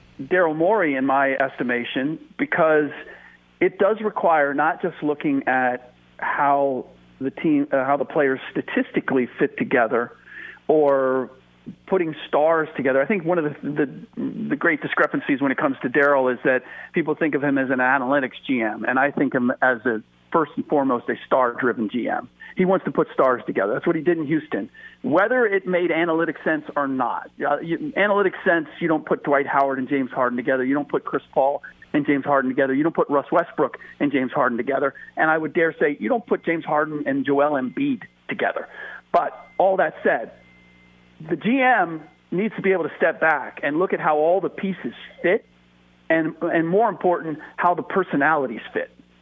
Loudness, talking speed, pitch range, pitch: -22 LUFS, 190 wpm, 135-180 Hz, 150 Hz